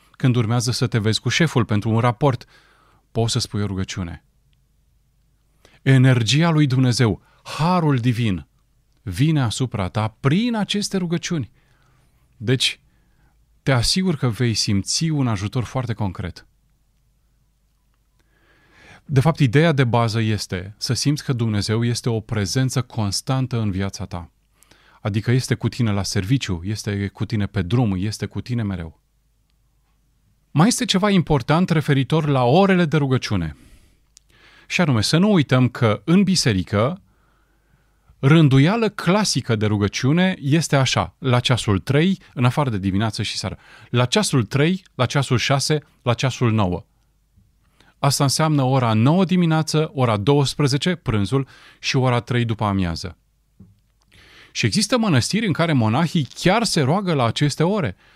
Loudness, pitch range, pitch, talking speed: -20 LUFS, 110-150 Hz, 130 Hz, 140 wpm